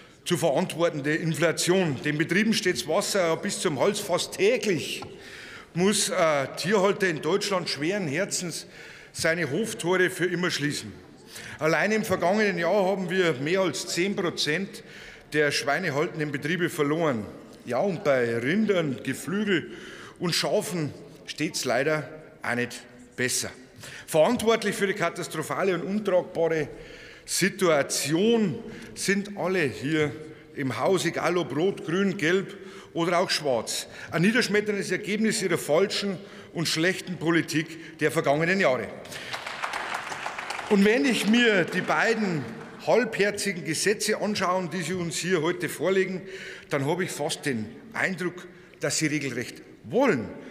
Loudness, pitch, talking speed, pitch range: -26 LUFS, 175 Hz, 125 wpm, 155-195 Hz